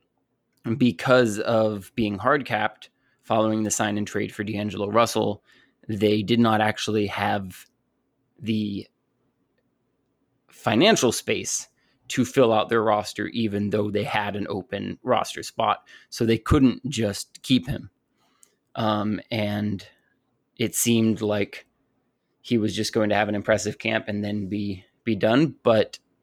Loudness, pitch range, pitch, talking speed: -24 LUFS, 105-115 Hz, 105 Hz, 135 wpm